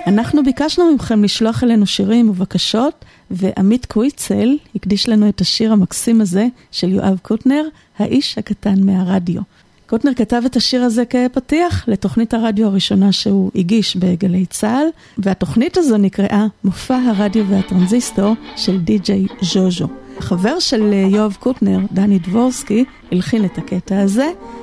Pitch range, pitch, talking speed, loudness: 195-240 Hz, 210 Hz, 130 wpm, -15 LUFS